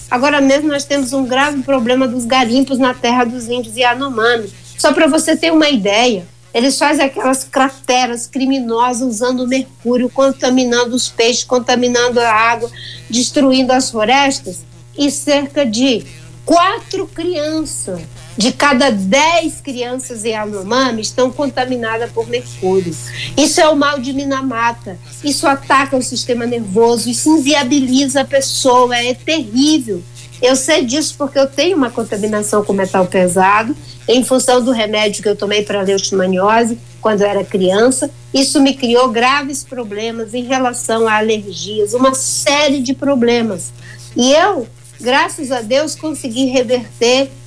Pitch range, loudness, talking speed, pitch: 215-275 Hz, -14 LUFS, 145 wpm, 250 Hz